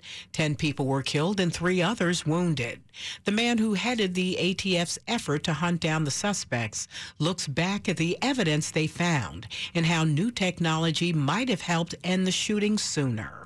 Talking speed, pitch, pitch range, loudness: 170 wpm, 170 Hz, 150-185 Hz, -27 LUFS